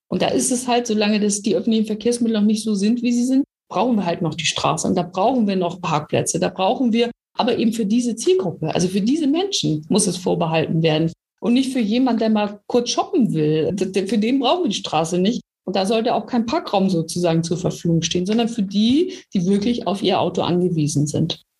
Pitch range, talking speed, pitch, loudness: 175-240 Hz, 225 wpm, 210 Hz, -20 LUFS